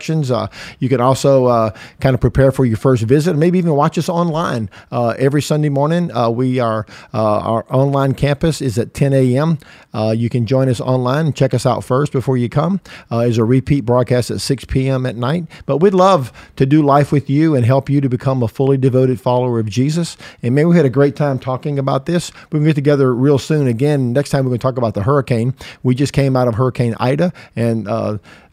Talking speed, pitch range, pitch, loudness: 225 wpm, 125-145 Hz, 135 Hz, -15 LUFS